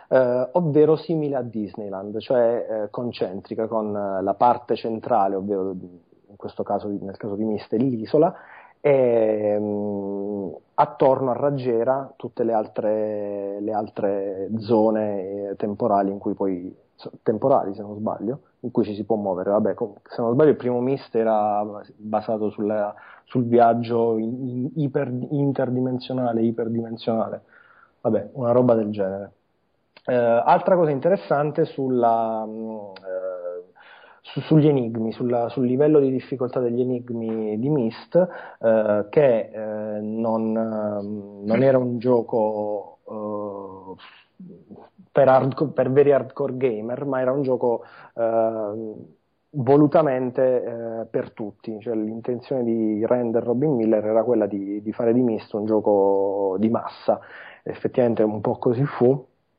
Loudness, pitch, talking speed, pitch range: -22 LUFS, 115 Hz, 140 wpm, 105-125 Hz